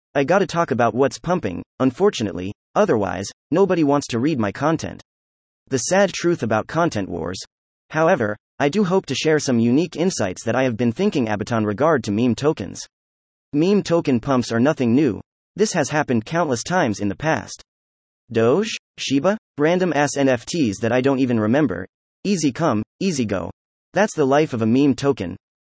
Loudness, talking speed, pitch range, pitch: -20 LUFS, 175 wpm, 110-160 Hz, 135 Hz